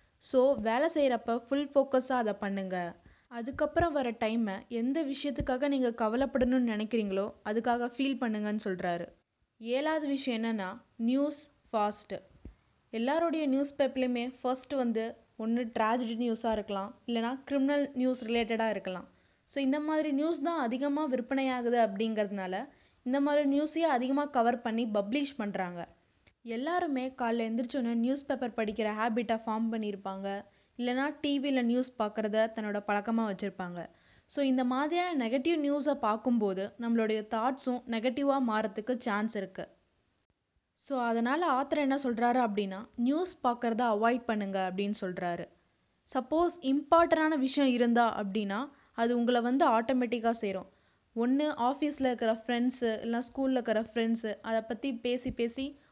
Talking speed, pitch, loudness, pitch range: 125 wpm, 240 Hz, -31 LUFS, 220-275 Hz